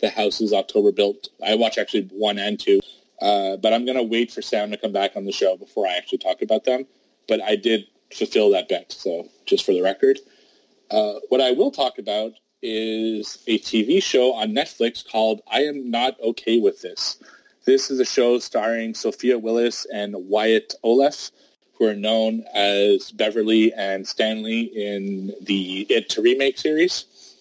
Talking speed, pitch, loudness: 185 wpm, 115 Hz, -21 LUFS